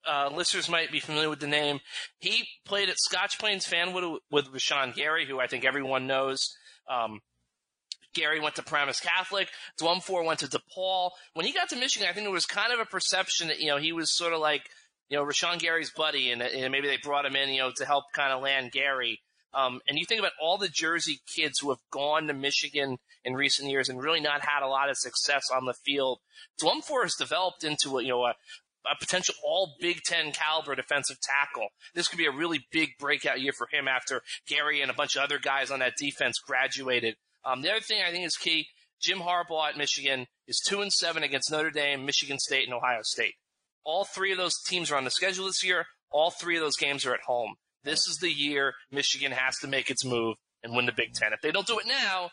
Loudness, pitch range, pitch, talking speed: -28 LUFS, 135-175 Hz, 150 Hz, 235 wpm